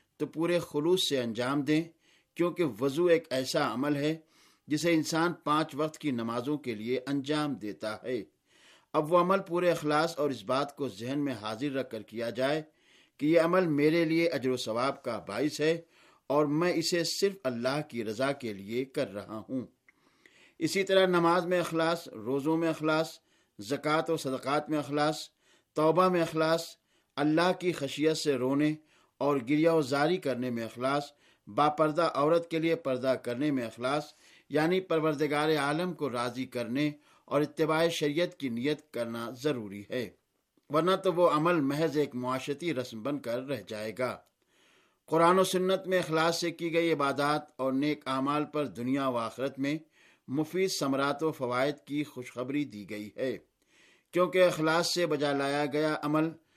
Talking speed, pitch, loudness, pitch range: 170 wpm, 150 Hz, -30 LUFS, 130-165 Hz